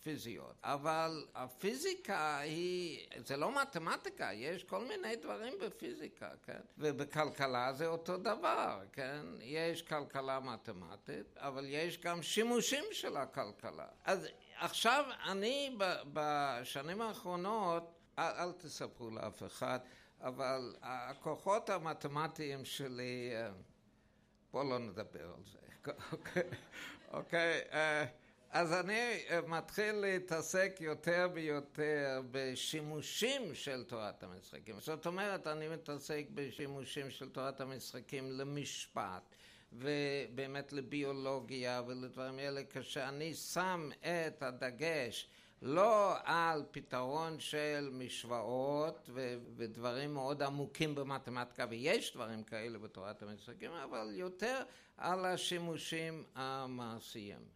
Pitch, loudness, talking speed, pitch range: 145 Hz, -40 LUFS, 95 wpm, 130-165 Hz